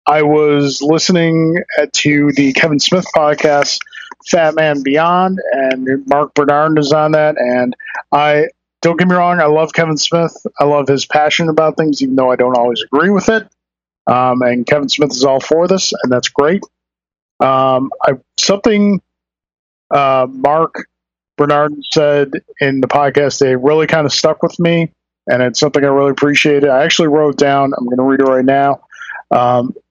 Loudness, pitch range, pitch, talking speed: -12 LUFS, 135-160 Hz, 145 Hz, 175 wpm